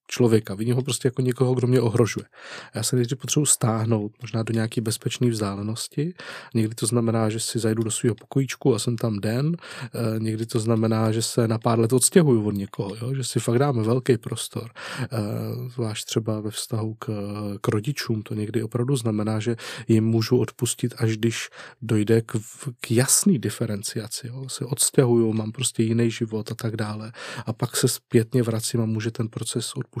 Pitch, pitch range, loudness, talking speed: 115 Hz, 110-125 Hz, -24 LUFS, 185 wpm